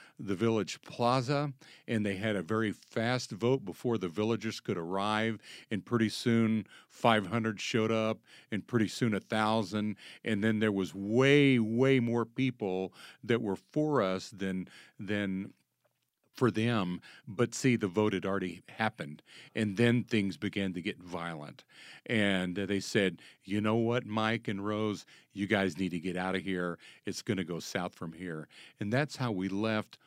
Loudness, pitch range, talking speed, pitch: -32 LUFS, 95-115 Hz, 170 wpm, 110 Hz